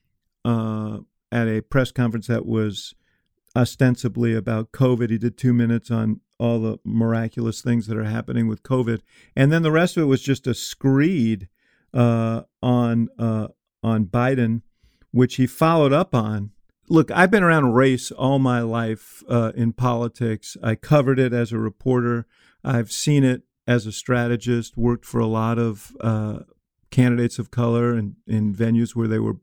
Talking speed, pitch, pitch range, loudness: 170 wpm, 115 Hz, 110-125 Hz, -21 LUFS